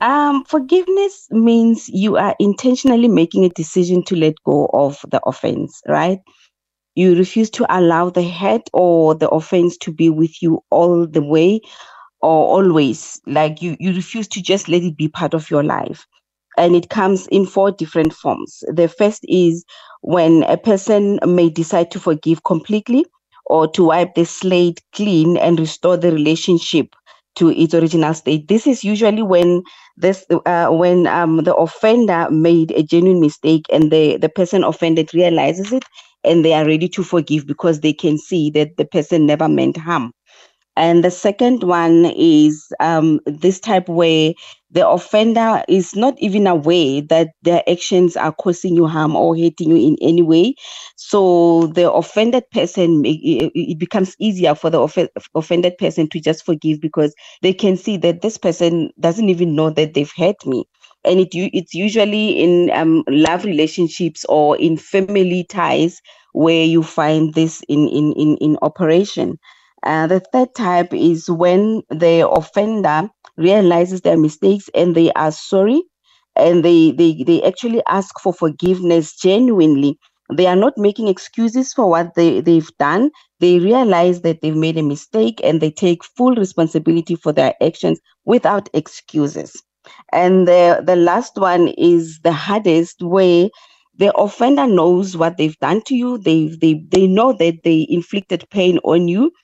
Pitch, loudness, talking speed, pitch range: 175 Hz, -15 LUFS, 165 wpm, 160-195 Hz